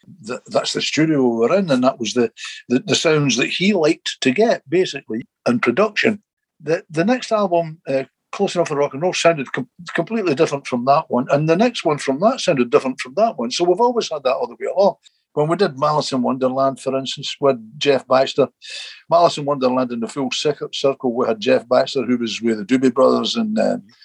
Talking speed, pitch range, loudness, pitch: 220 wpm, 130-180 Hz, -18 LUFS, 145 Hz